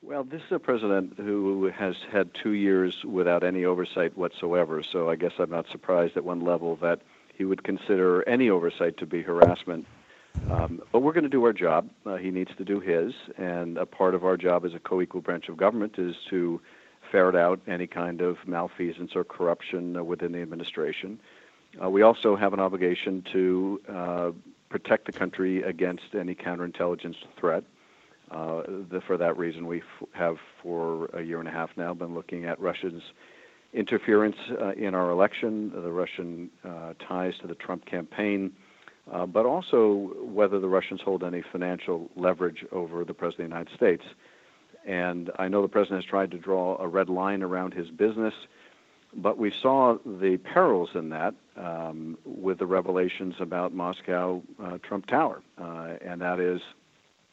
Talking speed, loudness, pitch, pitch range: 180 wpm, -27 LUFS, 90 Hz, 85-95 Hz